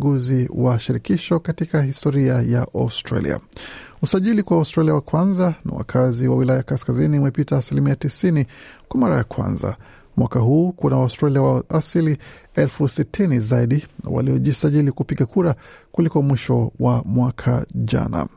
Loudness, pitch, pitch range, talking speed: -19 LUFS, 140 Hz, 125-155 Hz, 135 wpm